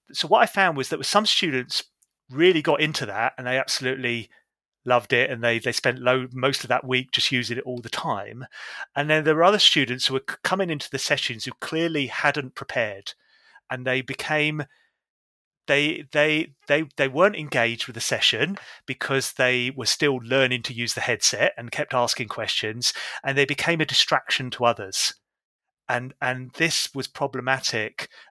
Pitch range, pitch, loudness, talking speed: 125-150 Hz, 130 Hz, -23 LUFS, 180 wpm